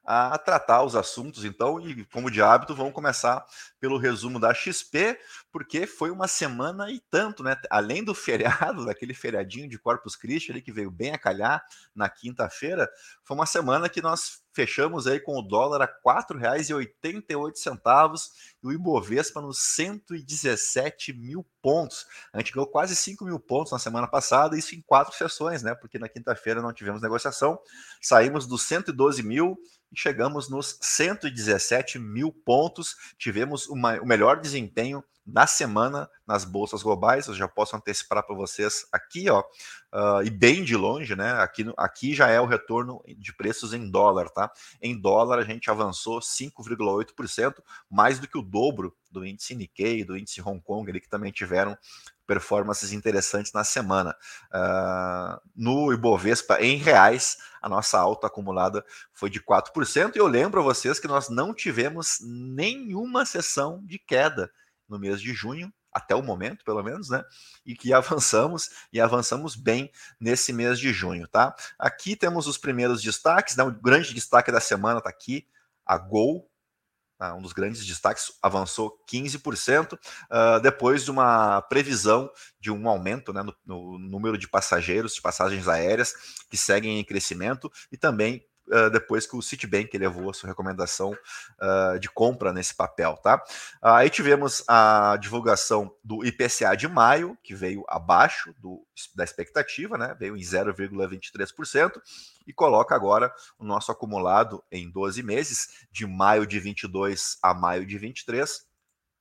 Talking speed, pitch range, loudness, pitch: 160 wpm, 100-140 Hz, -25 LUFS, 115 Hz